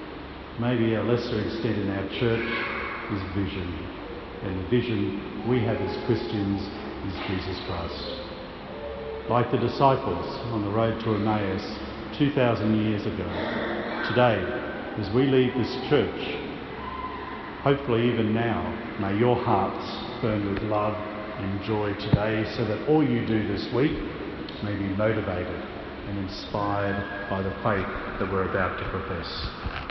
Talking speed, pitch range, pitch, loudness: 135 wpm, 100-115 Hz, 105 Hz, -27 LUFS